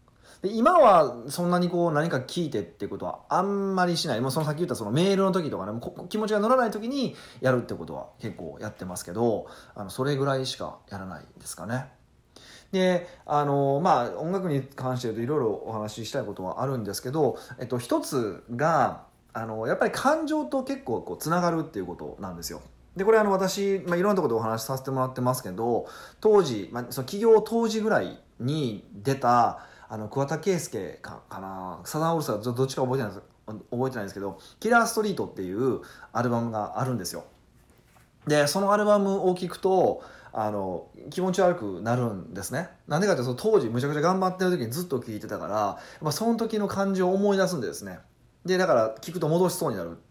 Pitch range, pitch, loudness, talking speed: 115-185 Hz, 140 Hz, -26 LUFS, 415 characters per minute